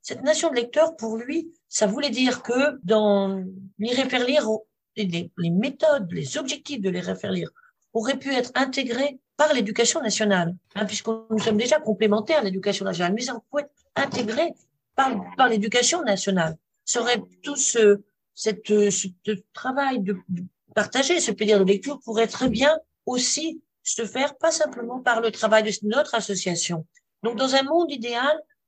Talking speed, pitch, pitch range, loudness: 165 wpm, 235 Hz, 210-285 Hz, -23 LUFS